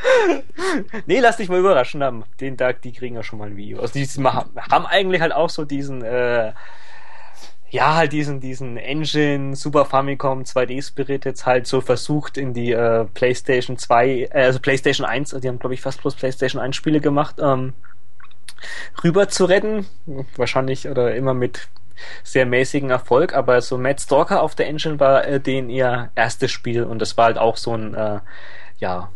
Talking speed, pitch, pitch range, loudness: 175 wpm, 130 Hz, 125-145 Hz, -19 LUFS